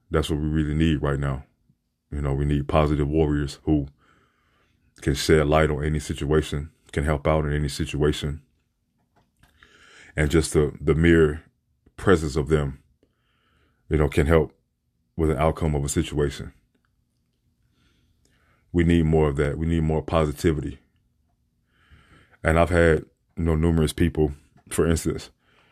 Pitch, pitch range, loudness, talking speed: 75 Hz, 75-80 Hz, -23 LUFS, 145 wpm